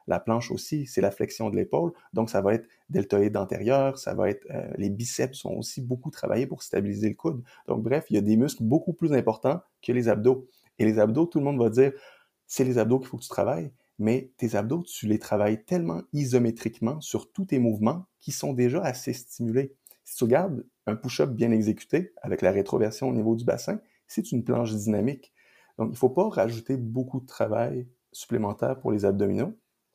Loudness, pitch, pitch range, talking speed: -27 LUFS, 120 Hz, 110-135 Hz, 210 wpm